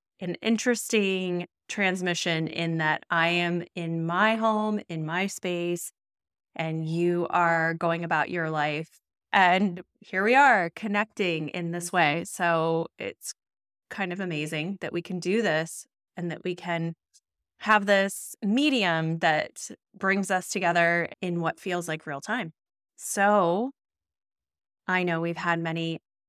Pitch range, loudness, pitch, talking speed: 165-200 Hz, -26 LUFS, 175 Hz, 140 wpm